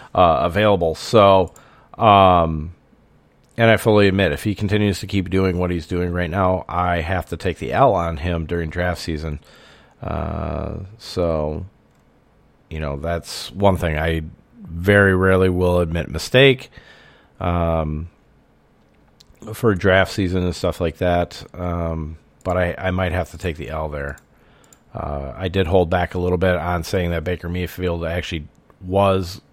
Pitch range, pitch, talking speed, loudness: 80-95 Hz, 90 Hz, 155 wpm, -19 LUFS